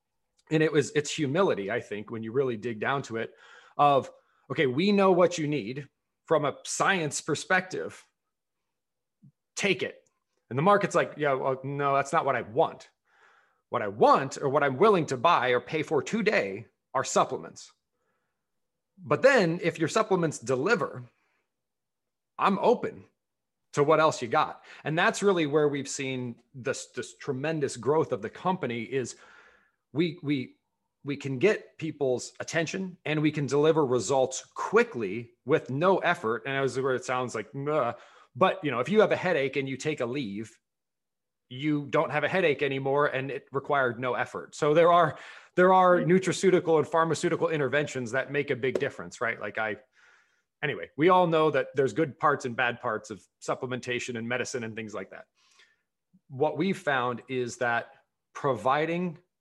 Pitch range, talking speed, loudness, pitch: 130-165 Hz, 170 wpm, -27 LUFS, 145 Hz